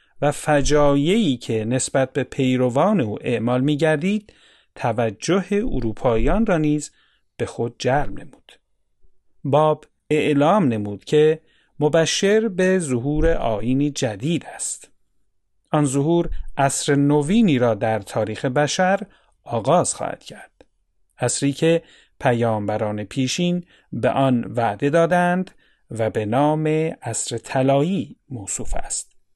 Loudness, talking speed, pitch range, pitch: -21 LUFS, 110 wpm, 120-160 Hz, 140 Hz